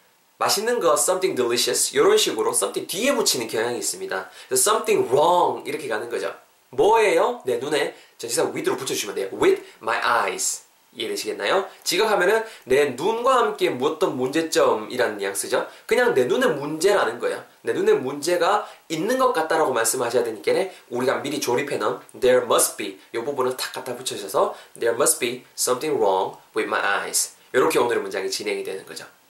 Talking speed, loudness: 510 characters per minute, -22 LUFS